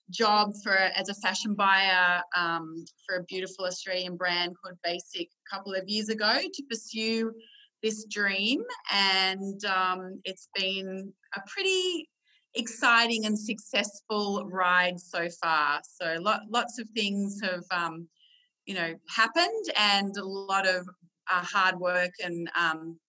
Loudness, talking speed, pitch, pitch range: -28 LUFS, 140 wpm, 195 Hz, 180-220 Hz